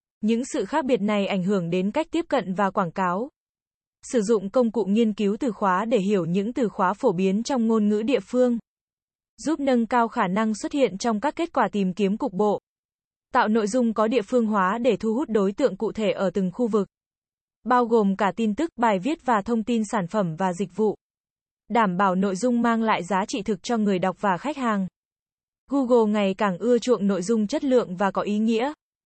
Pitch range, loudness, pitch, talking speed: 200-245 Hz, -23 LUFS, 220 Hz, 225 wpm